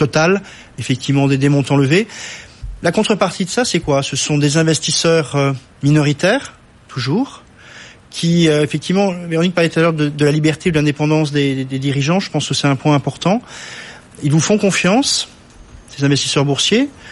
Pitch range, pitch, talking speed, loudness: 140-175 Hz, 150 Hz, 170 wpm, -15 LUFS